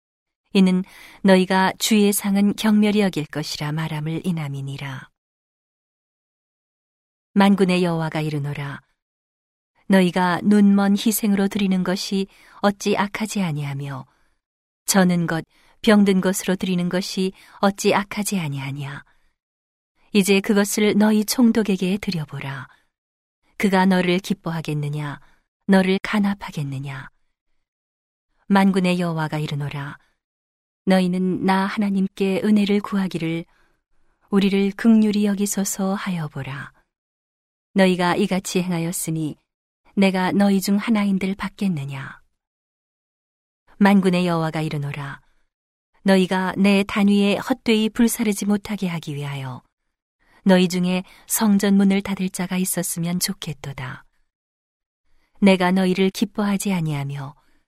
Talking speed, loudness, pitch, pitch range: 255 characters per minute, -20 LUFS, 185 Hz, 155-200 Hz